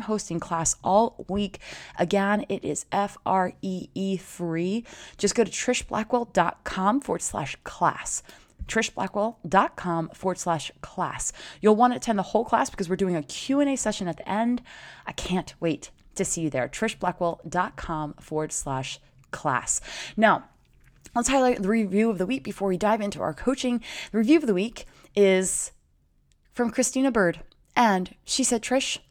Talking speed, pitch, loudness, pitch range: 155 wpm, 195 Hz, -26 LUFS, 170-230 Hz